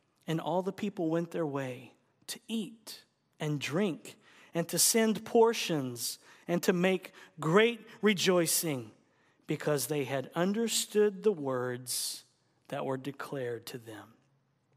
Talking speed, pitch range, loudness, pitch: 125 wpm, 135-205 Hz, -31 LUFS, 165 Hz